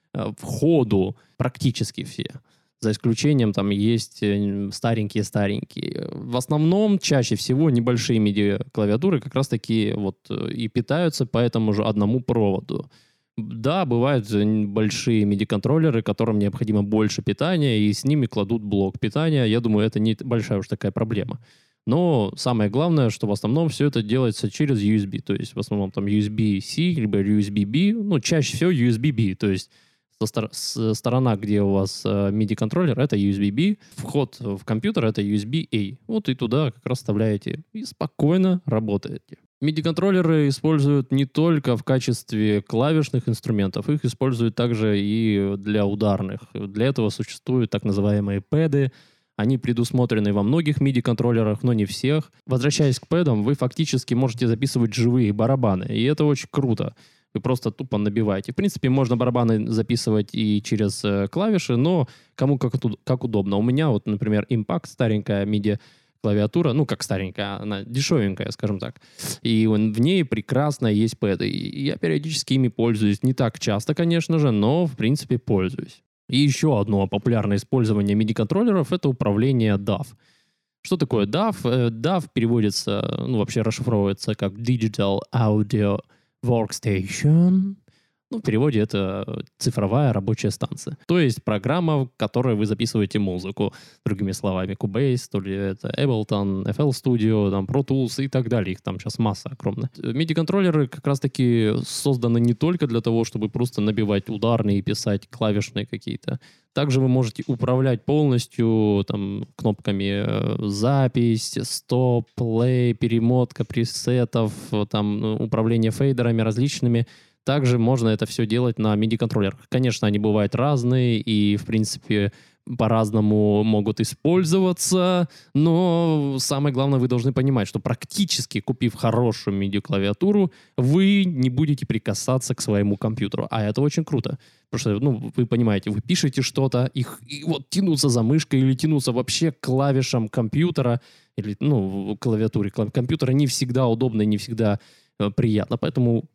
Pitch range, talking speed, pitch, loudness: 105-140 Hz, 140 wpm, 120 Hz, -22 LUFS